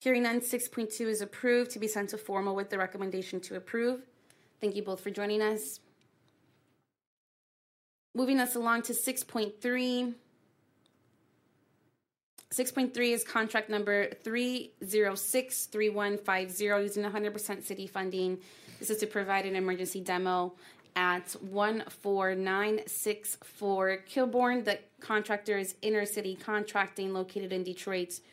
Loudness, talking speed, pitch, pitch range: -32 LUFS, 115 wpm, 210 Hz, 195-230 Hz